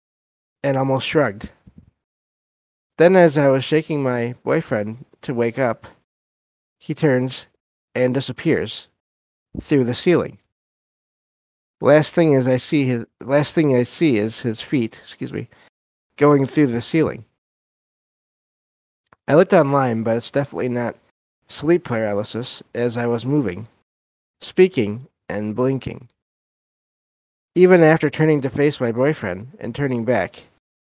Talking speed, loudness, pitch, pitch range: 125 wpm, -19 LUFS, 130 Hz, 115-150 Hz